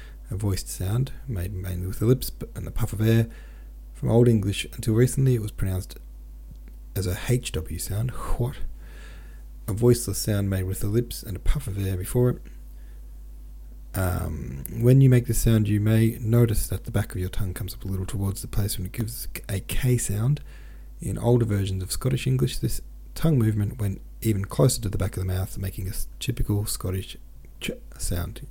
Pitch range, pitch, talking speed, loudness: 90-115 Hz, 100 Hz, 195 wpm, -26 LUFS